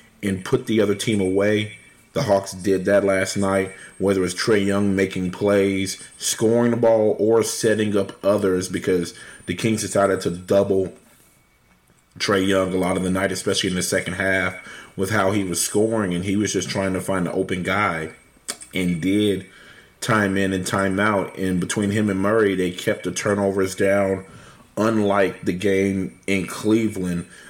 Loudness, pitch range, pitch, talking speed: -21 LUFS, 95-105 Hz, 95 Hz, 175 wpm